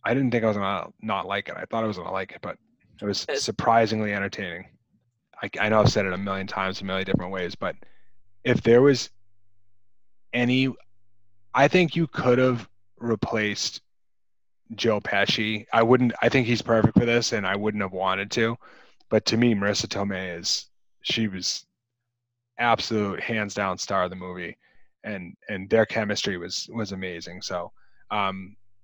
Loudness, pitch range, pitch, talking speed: -25 LUFS, 100-115 Hz, 105 Hz, 180 wpm